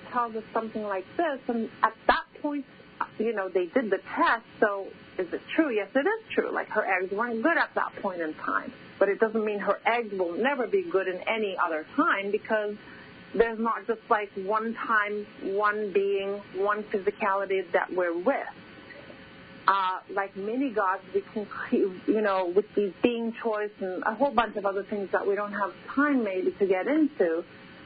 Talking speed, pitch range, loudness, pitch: 190 wpm, 195-230 Hz, -28 LUFS, 210 Hz